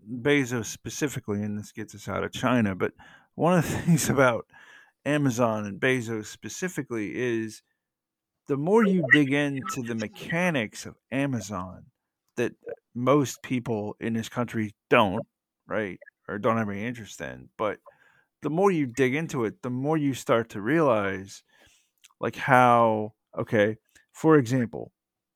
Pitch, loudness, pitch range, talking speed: 125 Hz, -26 LUFS, 110-145 Hz, 145 wpm